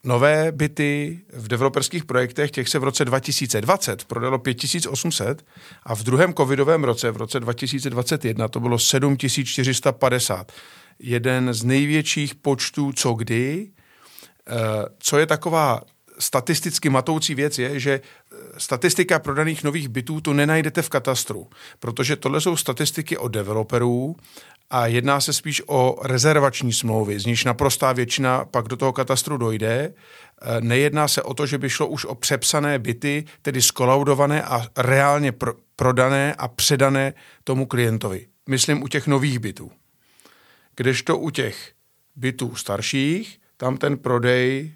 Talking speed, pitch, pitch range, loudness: 135 wpm, 135 Hz, 125-150 Hz, -21 LUFS